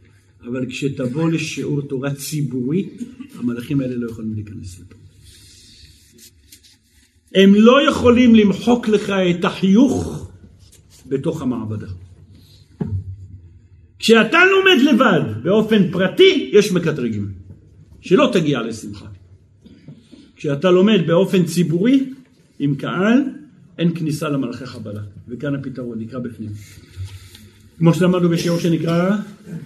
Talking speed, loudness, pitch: 95 wpm, -17 LUFS, 135 Hz